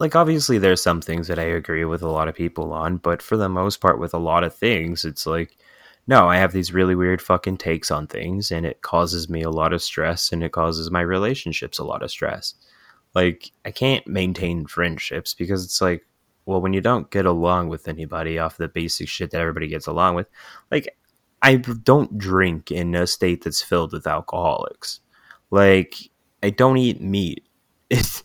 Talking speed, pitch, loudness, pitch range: 205 wpm, 90 Hz, -21 LUFS, 80-95 Hz